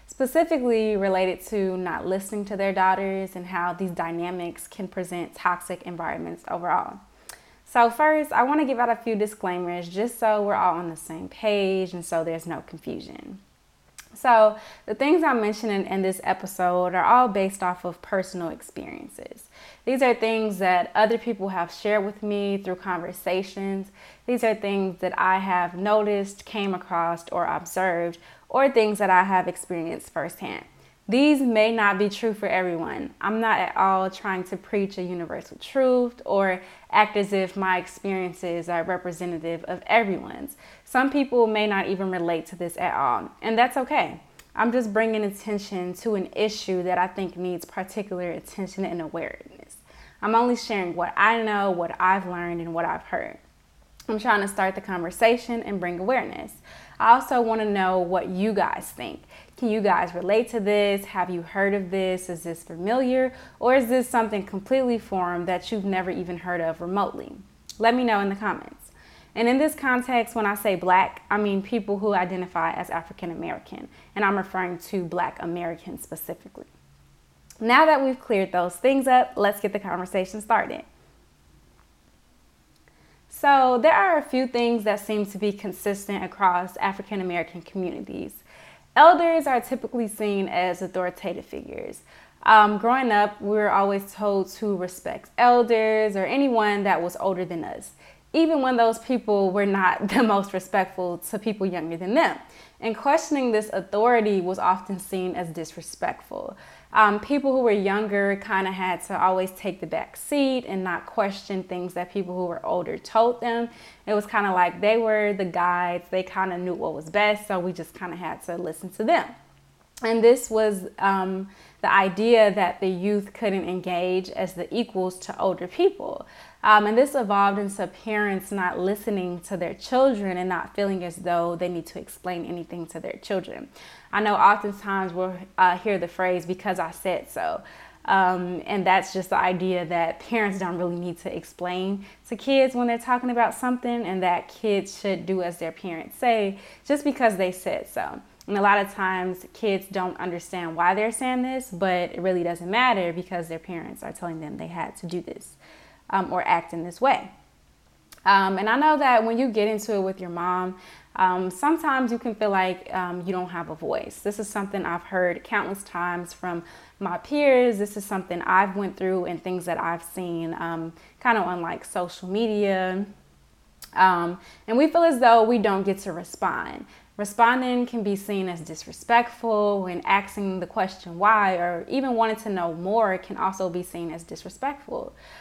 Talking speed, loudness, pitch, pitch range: 180 wpm, -24 LUFS, 195 Hz, 180-220 Hz